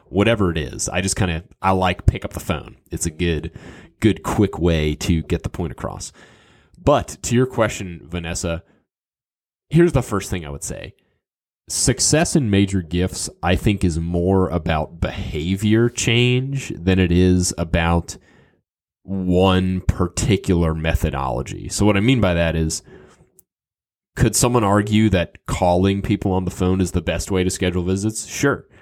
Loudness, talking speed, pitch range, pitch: -20 LUFS, 160 wpm, 85-105 Hz, 95 Hz